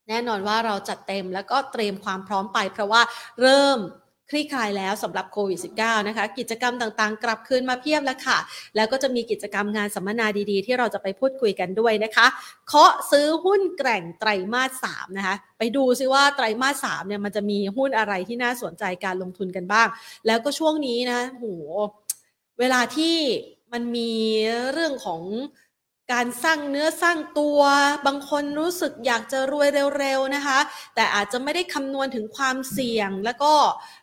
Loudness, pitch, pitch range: -23 LUFS, 240 Hz, 210-275 Hz